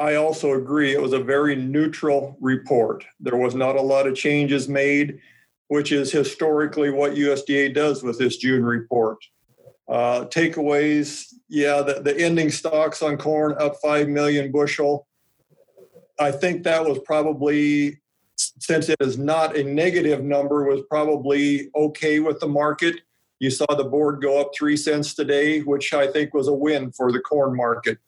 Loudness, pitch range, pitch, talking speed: -21 LUFS, 140-150 Hz, 145 Hz, 165 wpm